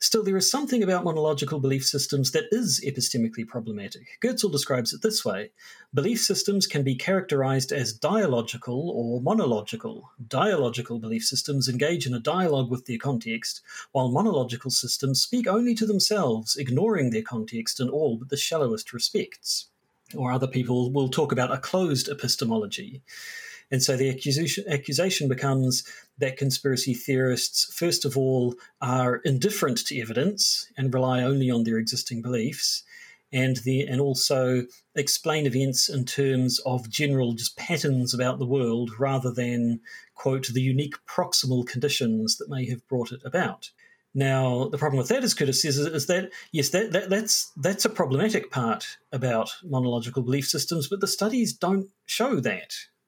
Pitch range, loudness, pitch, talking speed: 125-170 Hz, -25 LUFS, 135 Hz, 160 wpm